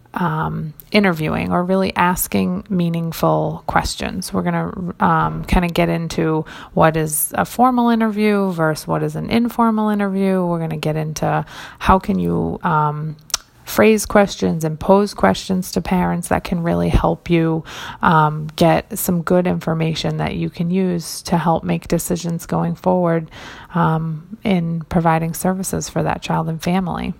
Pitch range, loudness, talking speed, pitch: 155-185 Hz, -18 LUFS, 155 wpm, 170 Hz